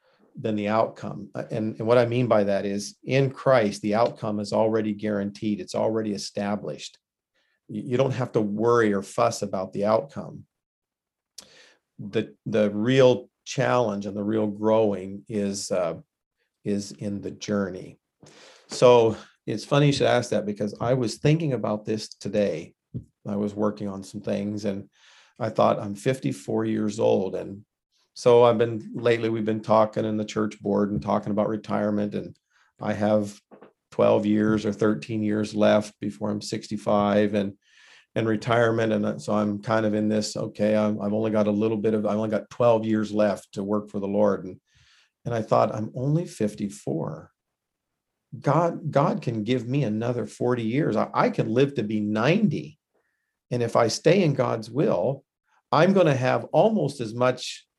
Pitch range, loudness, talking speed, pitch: 105-120 Hz, -24 LUFS, 170 wpm, 110 Hz